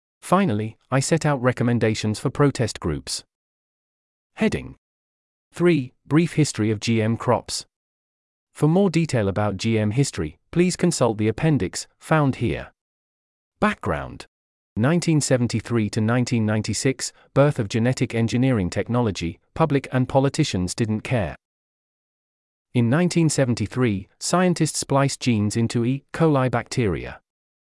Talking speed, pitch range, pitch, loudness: 110 wpm, 105-140 Hz, 120 Hz, -22 LUFS